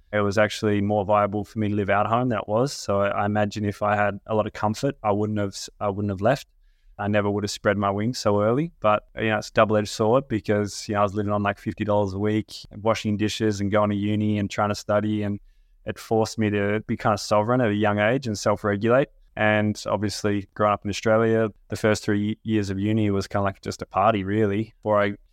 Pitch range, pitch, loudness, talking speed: 100-110 Hz, 105 Hz, -24 LUFS, 255 wpm